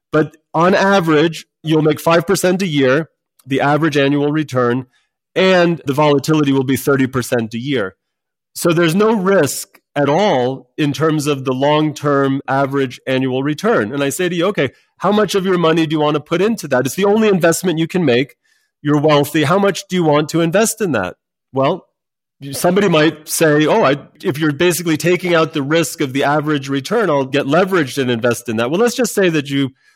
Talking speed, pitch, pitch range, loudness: 200 wpm, 155 Hz, 140-180 Hz, -15 LUFS